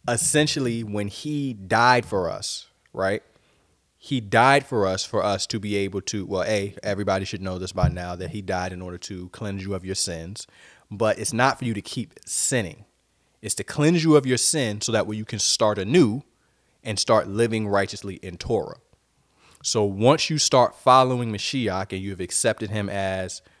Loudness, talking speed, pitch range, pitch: -23 LUFS, 190 wpm, 95-120 Hz, 105 Hz